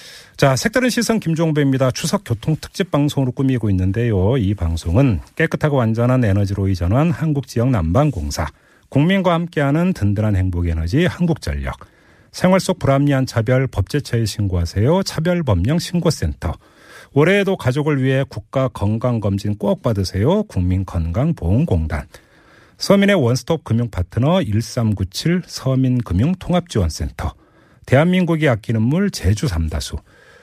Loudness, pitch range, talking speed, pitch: -18 LUFS, 100-160 Hz, 320 characters per minute, 125 Hz